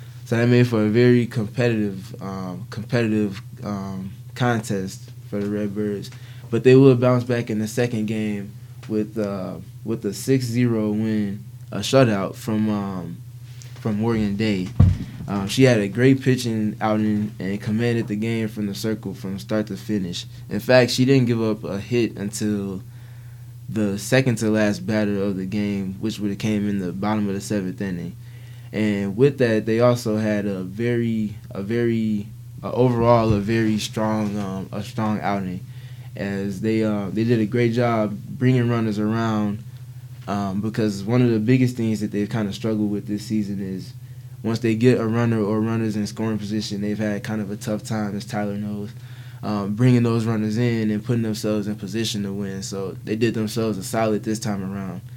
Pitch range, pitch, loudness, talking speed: 105-120 Hz, 110 Hz, -22 LUFS, 185 wpm